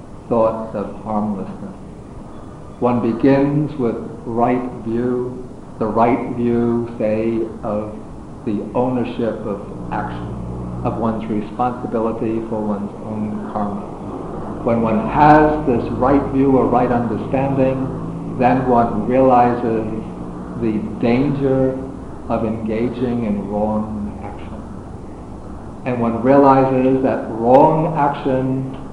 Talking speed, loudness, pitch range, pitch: 100 wpm, -18 LUFS, 110-130 Hz, 115 Hz